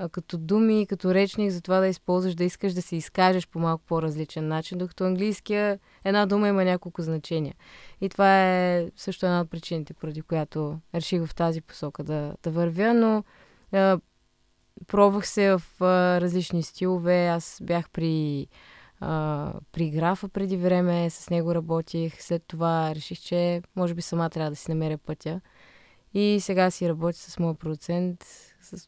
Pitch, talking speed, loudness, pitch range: 175 Hz, 160 wpm, -26 LUFS, 165-190 Hz